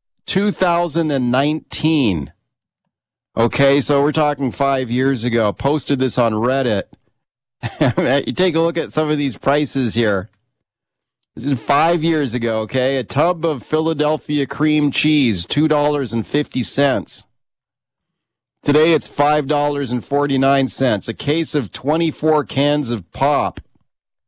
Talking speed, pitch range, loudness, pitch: 110 wpm, 125-150 Hz, -17 LUFS, 140 Hz